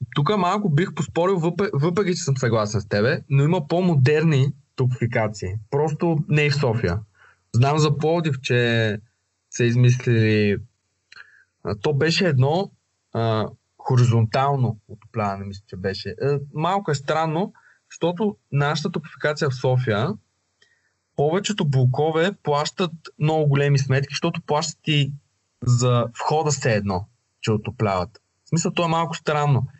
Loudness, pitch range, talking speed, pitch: -22 LUFS, 115-160 Hz, 130 wpm, 140 Hz